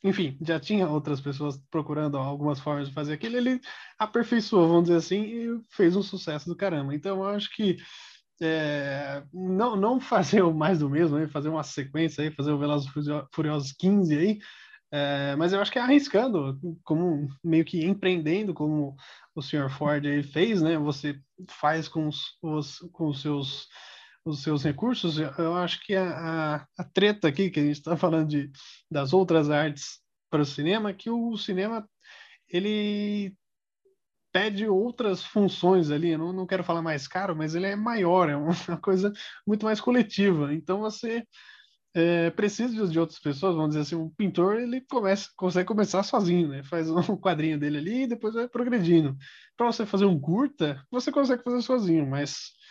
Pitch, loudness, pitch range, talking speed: 175 Hz, -27 LUFS, 150-205 Hz, 180 wpm